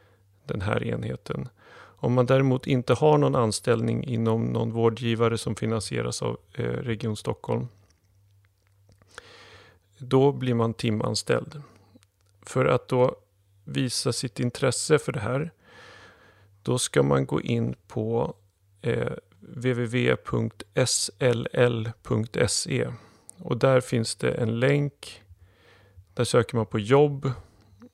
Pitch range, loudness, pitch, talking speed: 100-125 Hz, -26 LUFS, 115 Hz, 105 wpm